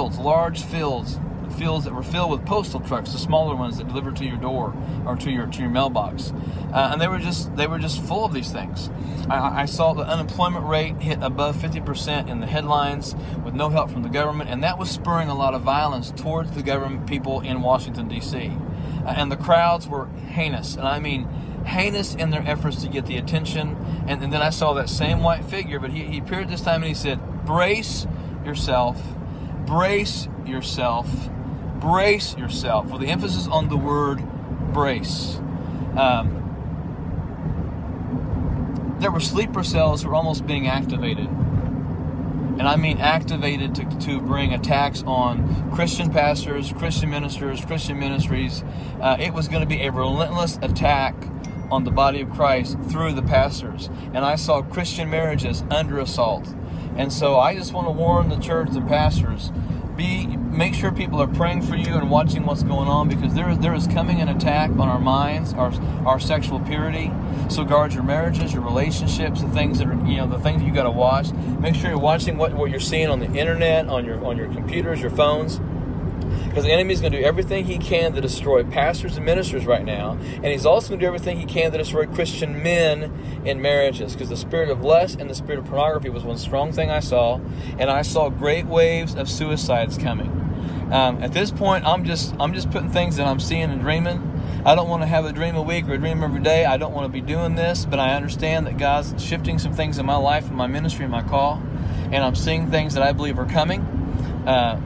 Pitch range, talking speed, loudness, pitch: 130-155 Hz, 205 wpm, -22 LUFS, 145 Hz